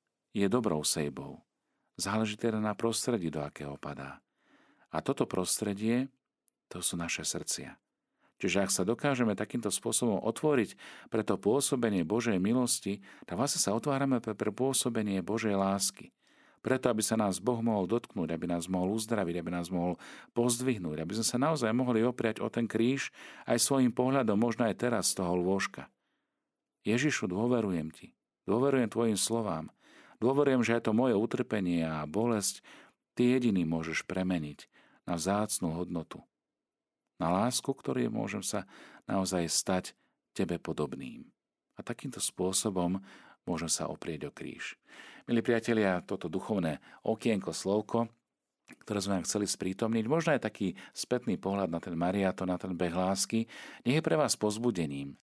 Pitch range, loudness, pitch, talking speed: 90-115 Hz, -31 LUFS, 105 Hz, 150 wpm